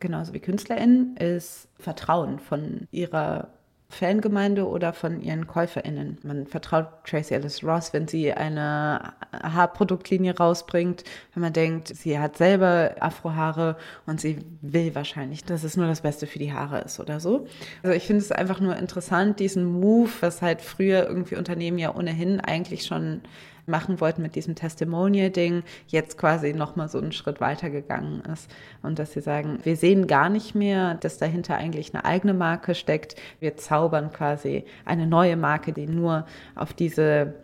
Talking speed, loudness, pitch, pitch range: 165 wpm, -25 LUFS, 165 Hz, 155-180 Hz